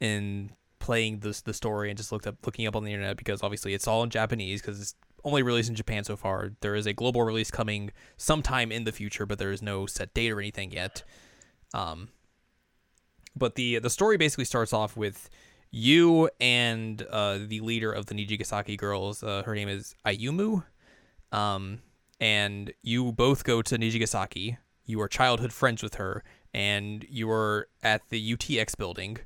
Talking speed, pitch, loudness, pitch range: 185 wpm, 110 Hz, -28 LUFS, 105-115 Hz